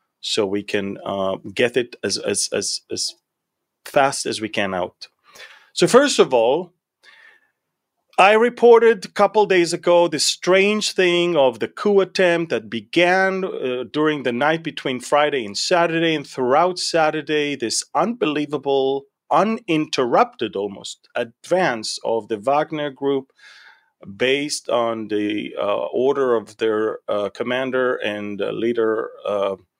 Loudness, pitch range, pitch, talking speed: -19 LUFS, 115-175 Hz, 145 Hz, 135 wpm